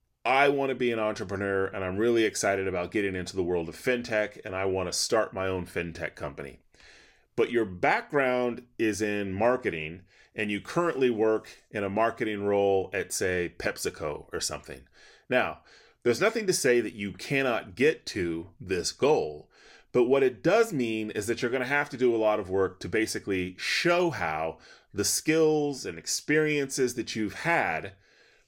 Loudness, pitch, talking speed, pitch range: -28 LUFS, 110 Hz, 180 wpm, 95-130 Hz